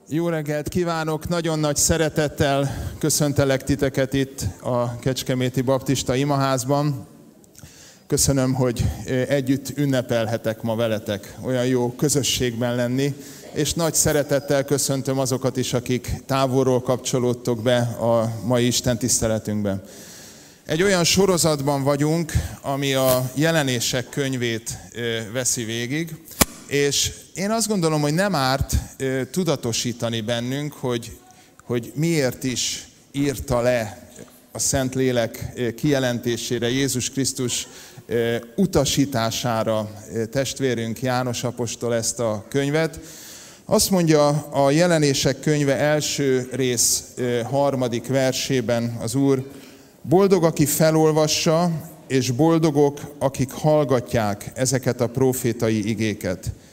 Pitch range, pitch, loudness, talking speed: 120-145 Hz, 130 Hz, -21 LUFS, 105 wpm